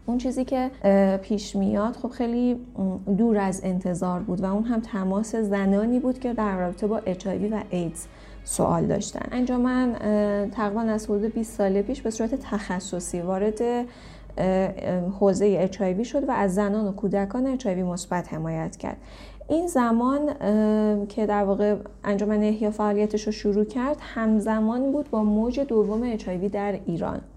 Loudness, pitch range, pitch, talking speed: -25 LUFS, 195-235 Hz, 210 Hz, 150 wpm